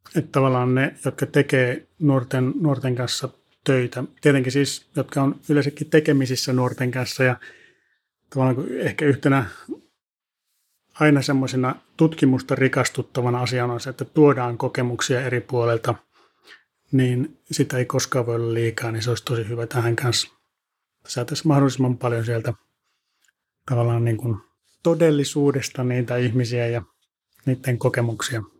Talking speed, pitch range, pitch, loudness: 125 wpm, 120-140 Hz, 130 Hz, -22 LUFS